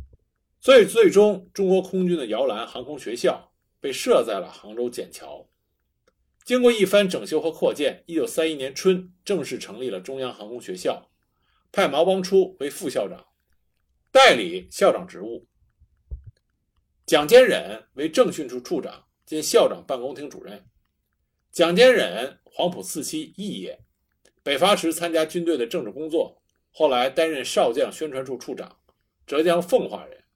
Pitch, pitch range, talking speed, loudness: 180 Hz, 155-205 Hz, 225 characters per minute, -22 LUFS